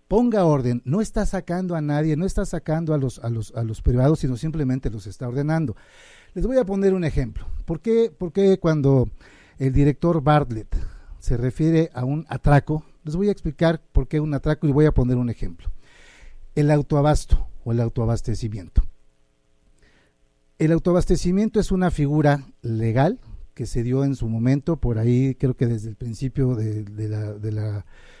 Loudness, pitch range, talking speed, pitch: -22 LUFS, 115-160 Hz, 175 wpm, 140 Hz